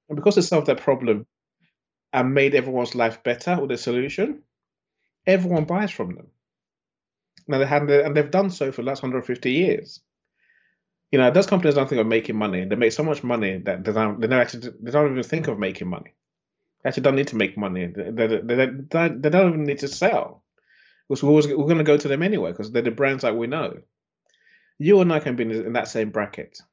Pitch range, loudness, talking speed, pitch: 120-160 Hz, -22 LUFS, 225 wpm, 140 Hz